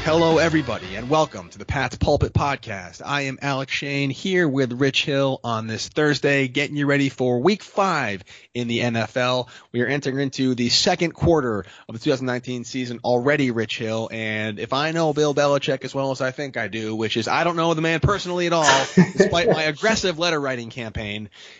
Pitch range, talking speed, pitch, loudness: 115-150 Hz, 200 wpm, 135 Hz, -21 LUFS